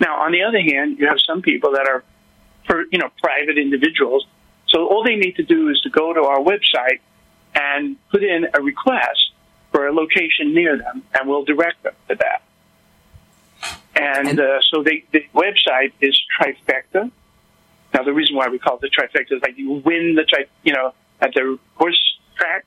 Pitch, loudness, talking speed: 155 Hz, -17 LUFS, 195 wpm